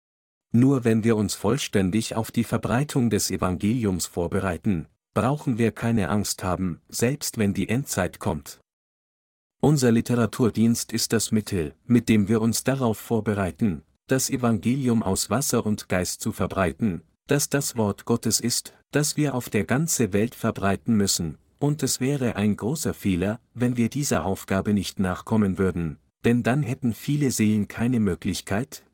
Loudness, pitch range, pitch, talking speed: -24 LUFS, 100-120 Hz, 115 Hz, 150 wpm